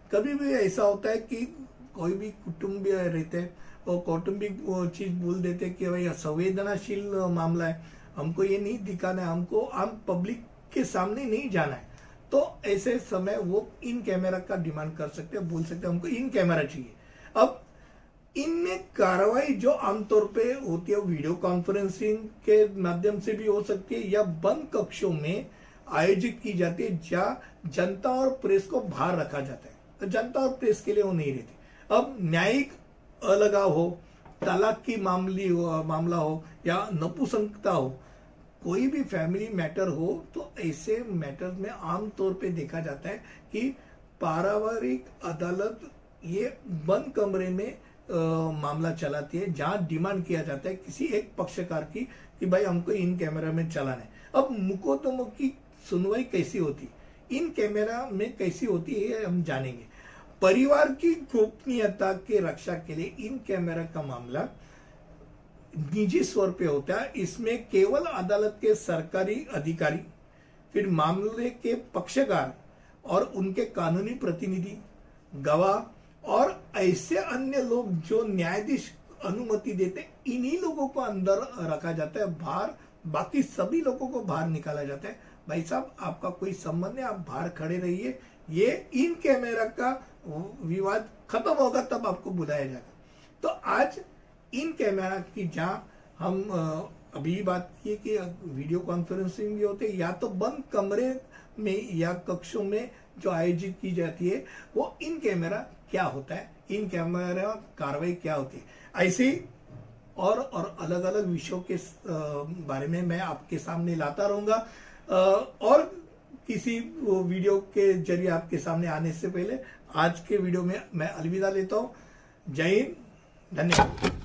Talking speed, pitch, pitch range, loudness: 155 wpm, 190 Hz, 170-215 Hz, -29 LUFS